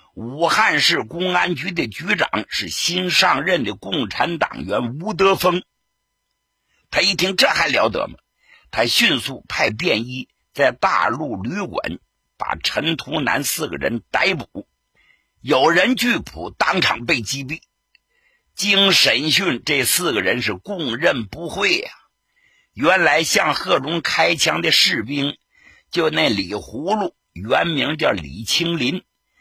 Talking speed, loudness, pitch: 190 characters per minute, -18 LUFS, 180 Hz